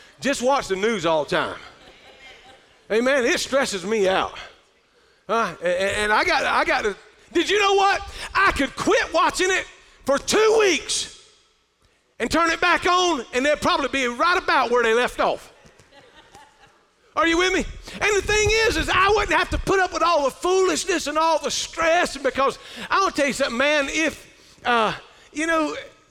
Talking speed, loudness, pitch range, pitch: 185 wpm, -21 LUFS, 270-375 Hz, 325 Hz